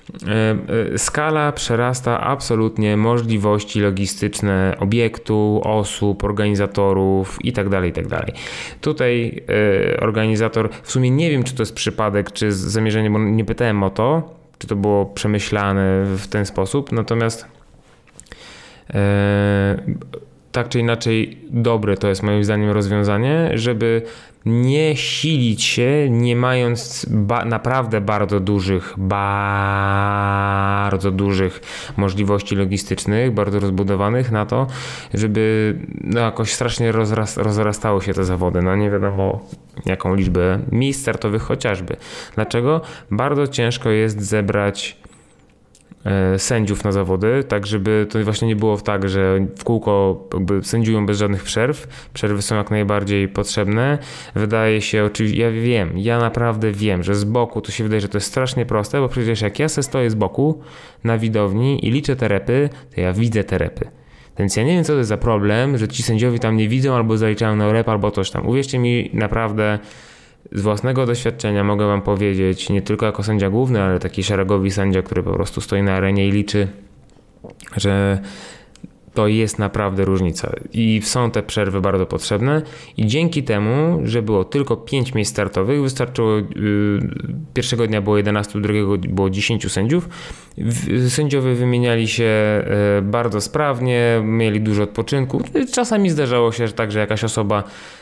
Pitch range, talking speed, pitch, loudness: 100-120 Hz, 145 wpm, 110 Hz, -19 LUFS